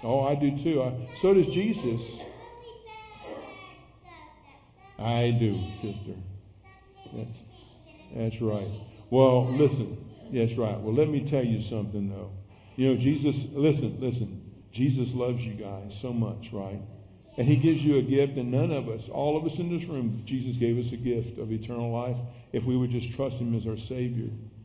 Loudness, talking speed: -28 LUFS, 175 wpm